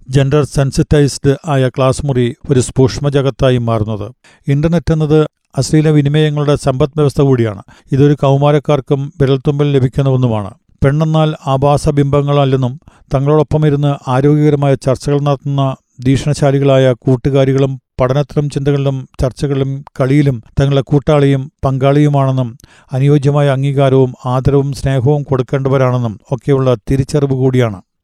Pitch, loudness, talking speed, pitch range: 140 Hz, -13 LUFS, 90 wpm, 130-145 Hz